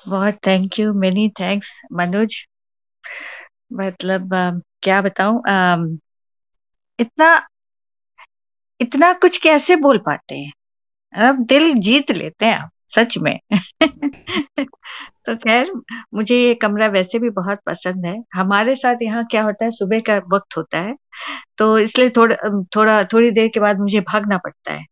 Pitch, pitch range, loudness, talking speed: 215 Hz, 190-240 Hz, -16 LUFS, 135 wpm